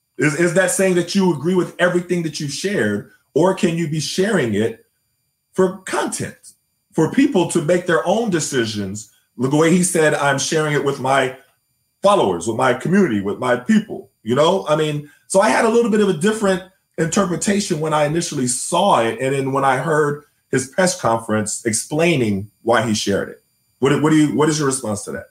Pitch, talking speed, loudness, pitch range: 155 Hz, 200 wpm, -18 LUFS, 130-180 Hz